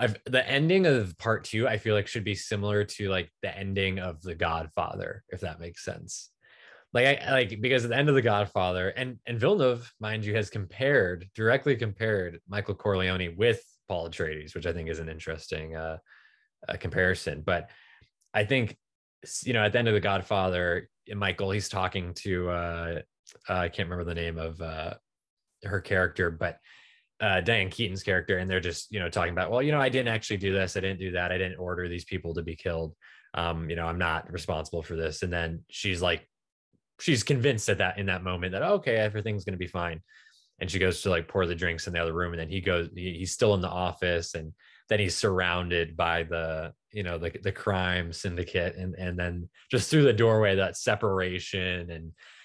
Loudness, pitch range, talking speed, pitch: -28 LUFS, 85-105 Hz, 210 wpm, 95 Hz